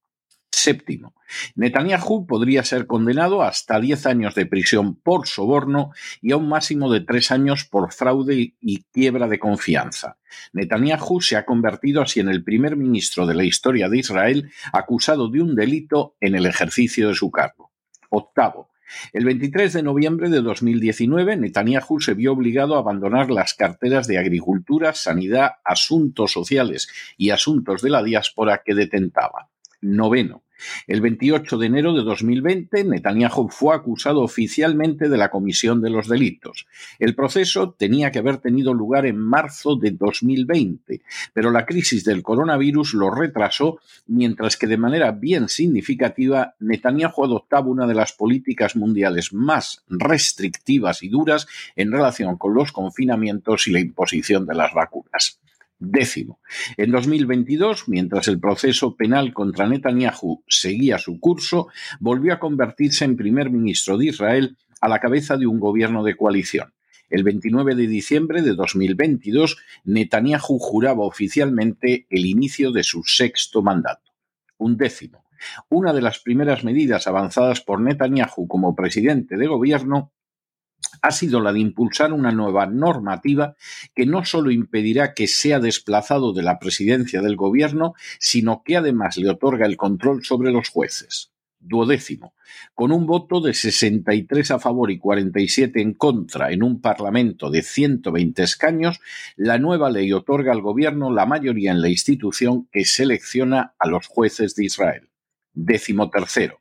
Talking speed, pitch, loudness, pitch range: 150 wpm, 120 Hz, -19 LUFS, 105-145 Hz